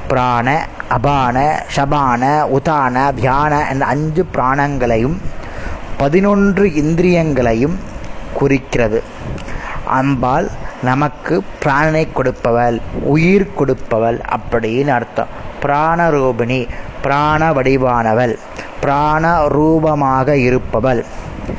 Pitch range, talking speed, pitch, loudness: 125-150 Hz, 65 wpm, 140 Hz, -15 LUFS